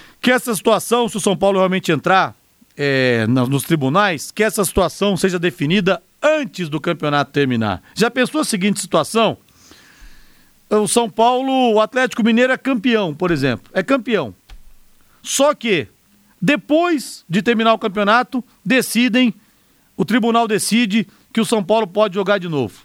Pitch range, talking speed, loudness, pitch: 180-235 Hz, 150 wpm, -17 LUFS, 210 Hz